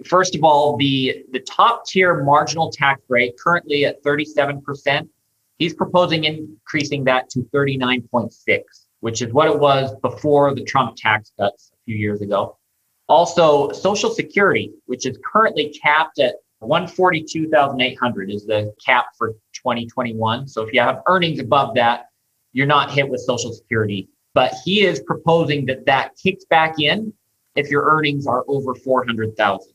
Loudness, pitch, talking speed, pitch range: -18 LUFS, 140 Hz, 150 wpm, 120-155 Hz